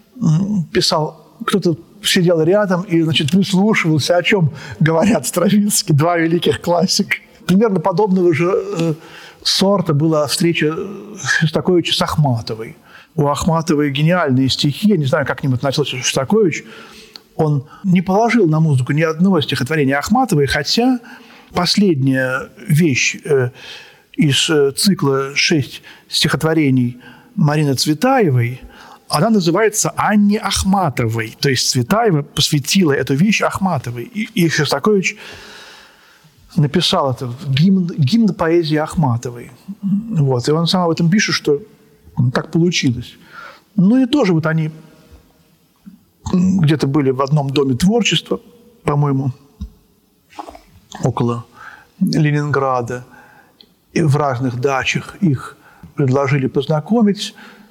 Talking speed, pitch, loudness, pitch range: 110 wpm, 165 Hz, -16 LUFS, 140-195 Hz